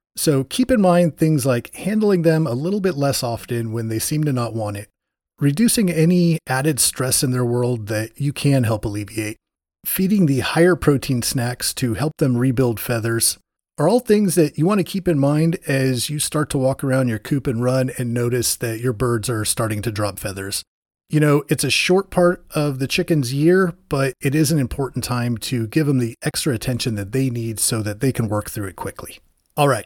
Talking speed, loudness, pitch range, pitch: 215 wpm, -19 LUFS, 115-155 Hz, 135 Hz